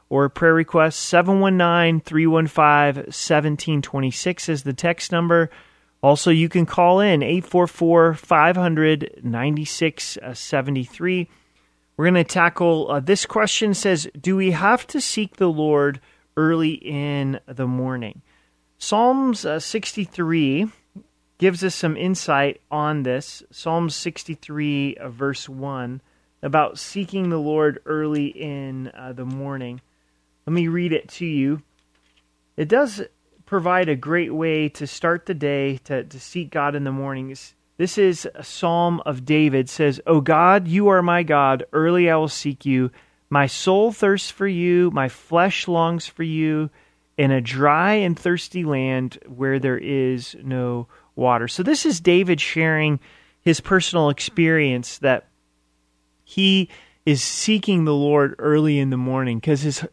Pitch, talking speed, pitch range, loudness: 155 Hz, 140 wpm, 135-175 Hz, -20 LUFS